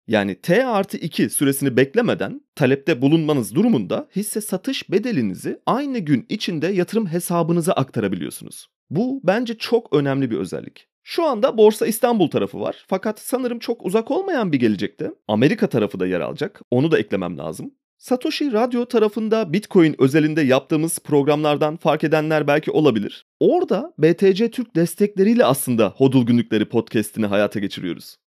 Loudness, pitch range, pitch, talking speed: -20 LUFS, 140-230 Hz, 175 Hz, 140 wpm